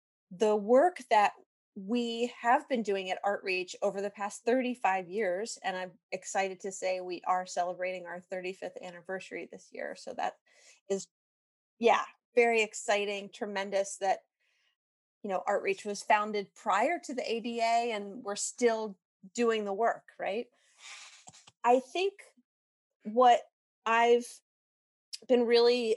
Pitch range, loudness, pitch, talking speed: 190-235 Hz, -31 LUFS, 205 Hz, 130 wpm